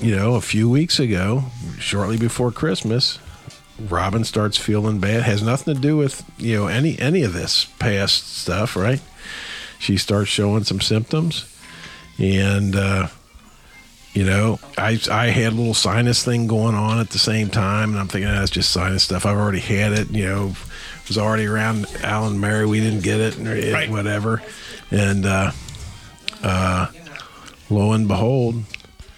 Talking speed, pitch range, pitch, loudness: 170 wpm, 100-115 Hz, 105 Hz, -20 LUFS